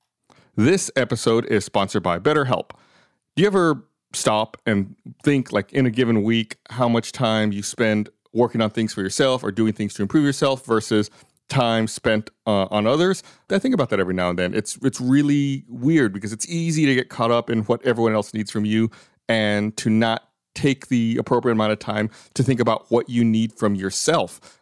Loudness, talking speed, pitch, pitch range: -21 LUFS, 200 wpm, 115 Hz, 105-130 Hz